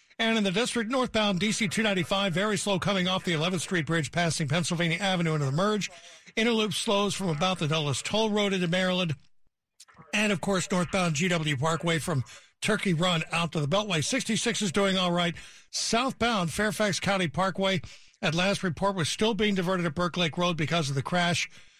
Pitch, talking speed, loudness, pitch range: 185 Hz, 185 wpm, -27 LUFS, 170-205 Hz